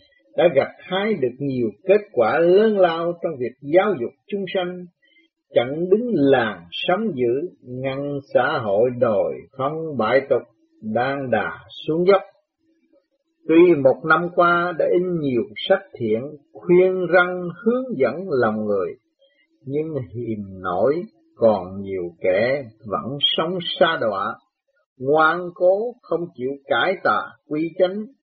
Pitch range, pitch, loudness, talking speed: 140-205 Hz, 175 Hz, -21 LUFS, 135 wpm